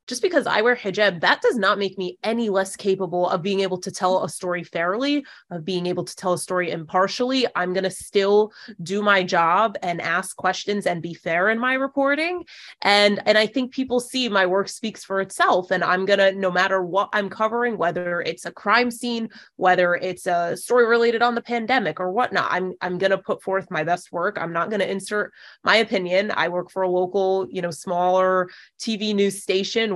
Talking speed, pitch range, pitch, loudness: 205 wpm, 180-220 Hz, 195 Hz, -22 LUFS